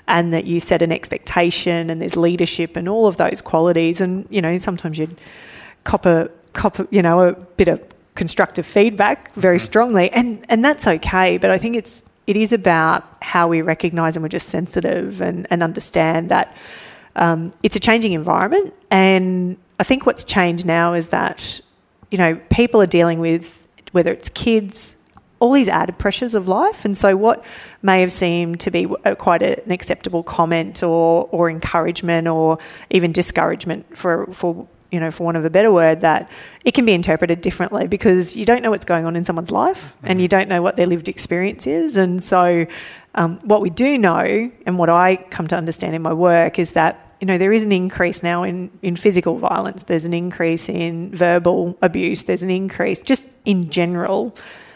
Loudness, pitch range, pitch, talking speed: -17 LUFS, 170-200 Hz, 180 Hz, 195 wpm